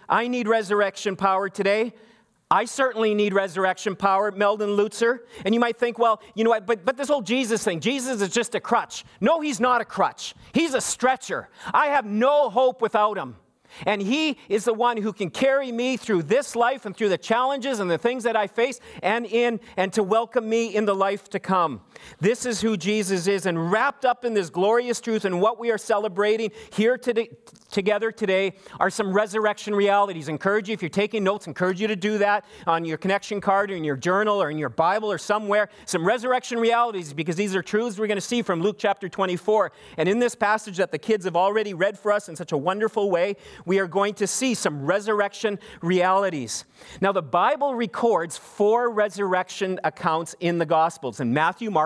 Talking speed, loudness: 210 wpm, -23 LUFS